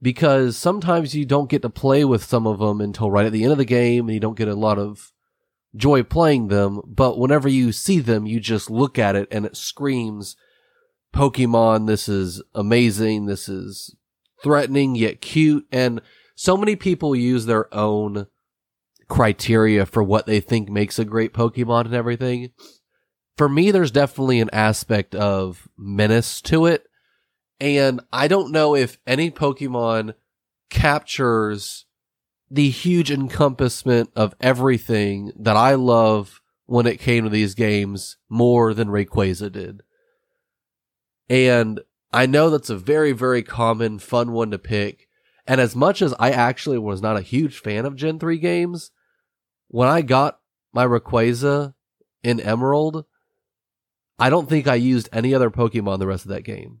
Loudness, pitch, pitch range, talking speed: -19 LUFS, 120 Hz, 110-140 Hz, 160 wpm